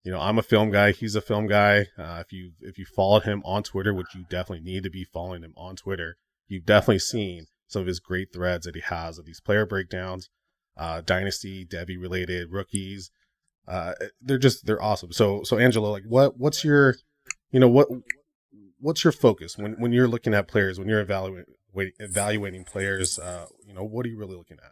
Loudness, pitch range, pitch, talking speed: -24 LUFS, 90-110 Hz, 100 Hz, 210 wpm